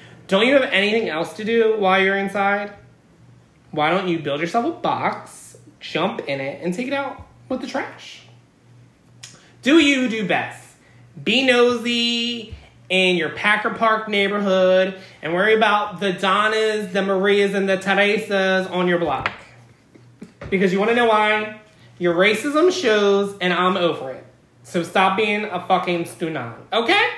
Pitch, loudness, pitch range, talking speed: 200 Hz, -19 LUFS, 180-220 Hz, 155 wpm